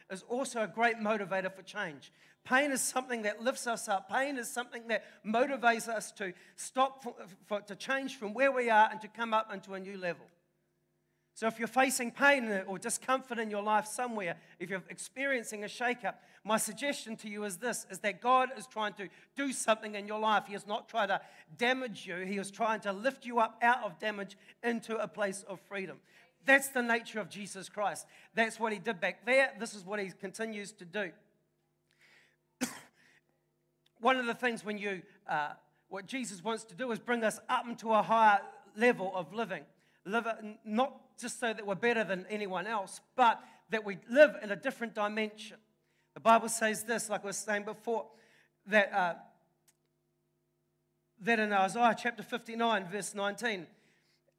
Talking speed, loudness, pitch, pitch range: 190 wpm, -33 LUFS, 215 Hz, 195-235 Hz